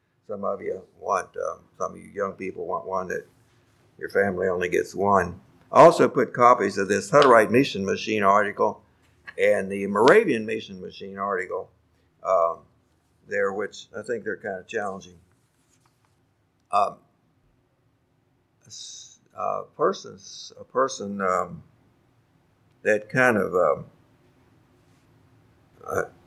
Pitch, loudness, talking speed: 125 Hz, -23 LUFS, 115 wpm